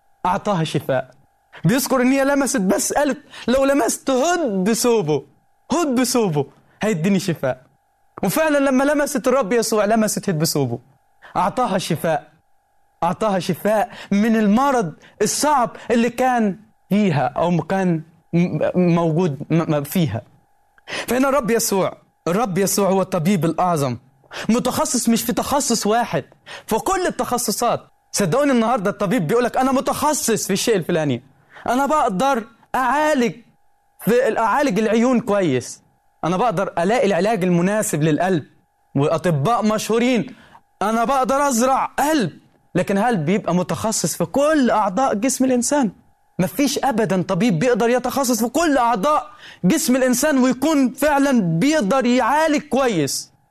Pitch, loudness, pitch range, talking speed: 225 Hz, -19 LUFS, 180-265 Hz, 120 wpm